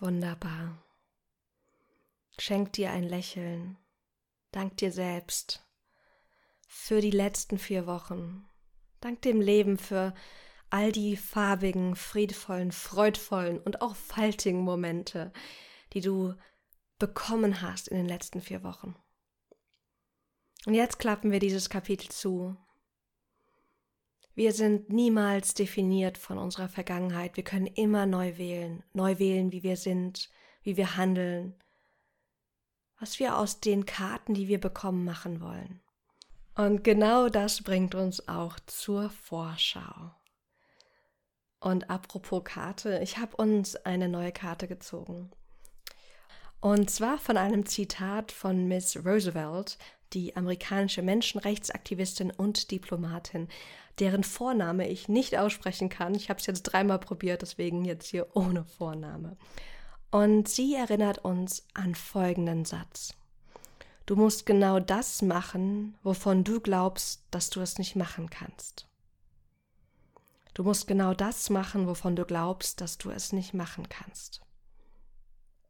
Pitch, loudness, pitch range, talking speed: 190 Hz, -30 LUFS, 180-205 Hz, 125 wpm